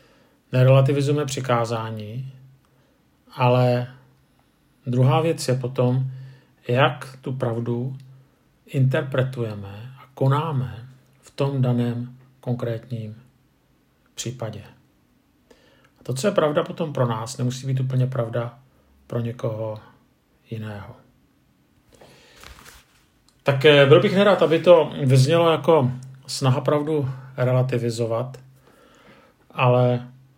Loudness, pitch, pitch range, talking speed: -21 LUFS, 130 Hz, 120-135 Hz, 90 wpm